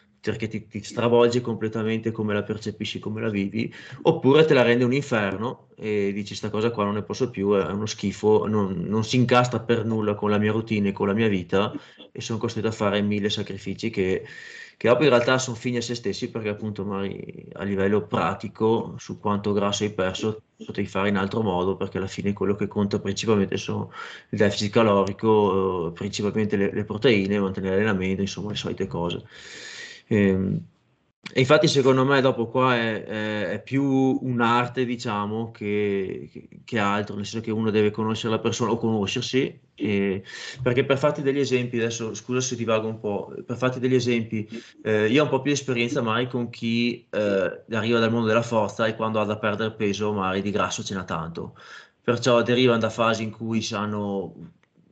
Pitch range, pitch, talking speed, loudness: 100-120 Hz, 110 Hz, 190 wpm, -24 LUFS